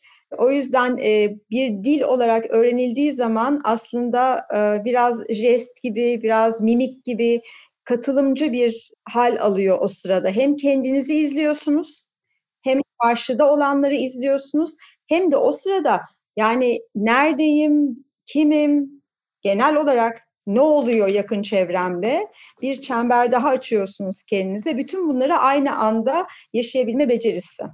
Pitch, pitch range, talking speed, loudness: 250 Hz, 230-285 Hz, 110 wpm, -20 LUFS